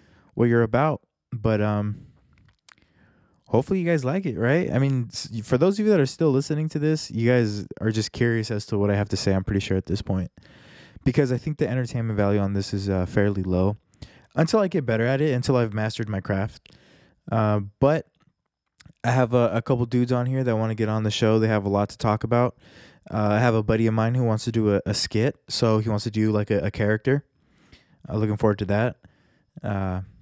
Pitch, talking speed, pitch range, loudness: 110 Hz, 230 wpm, 105-130 Hz, -24 LUFS